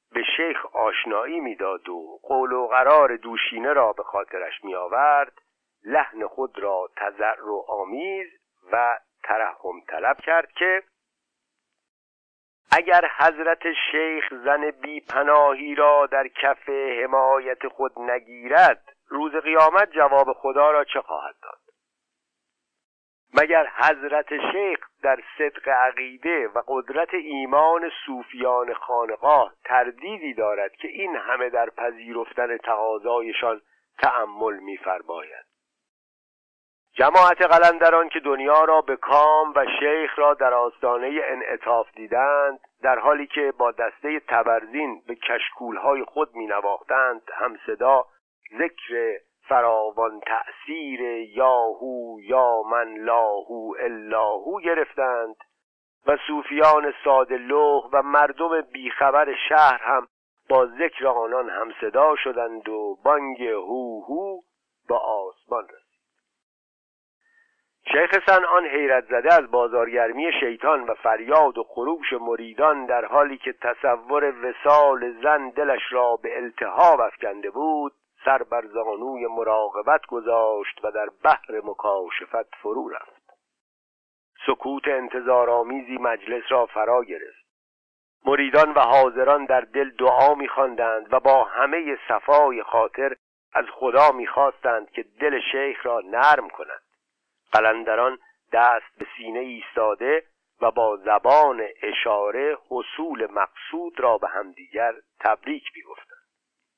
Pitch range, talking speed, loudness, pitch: 120-155 Hz, 115 wpm, -21 LUFS, 140 Hz